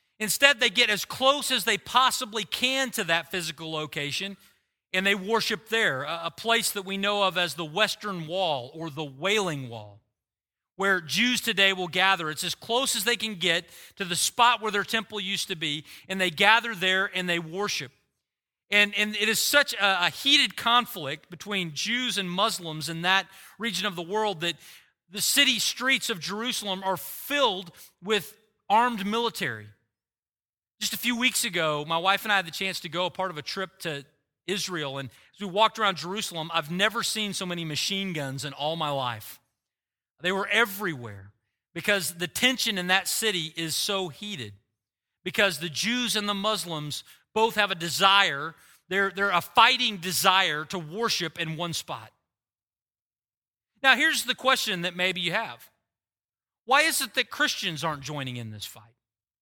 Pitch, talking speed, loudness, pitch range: 190 Hz, 180 wpm, -25 LUFS, 160-220 Hz